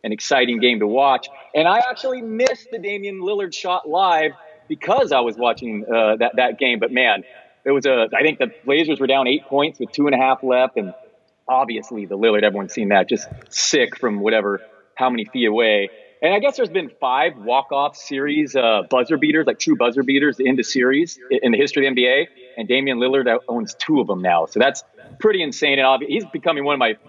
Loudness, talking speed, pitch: -18 LUFS, 220 wpm, 140 Hz